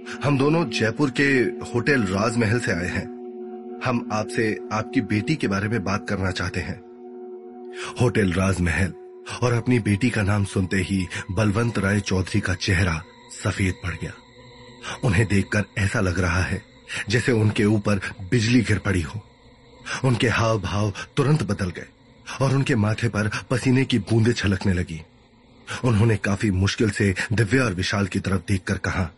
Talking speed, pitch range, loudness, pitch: 155 wpm, 95-120 Hz, -23 LUFS, 110 Hz